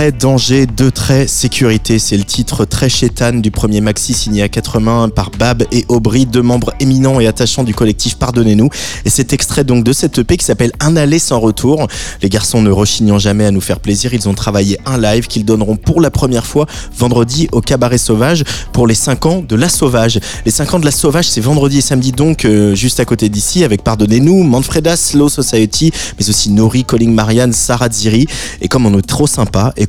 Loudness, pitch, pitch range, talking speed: -11 LUFS, 120 Hz, 110-135 Hz, 215 wpm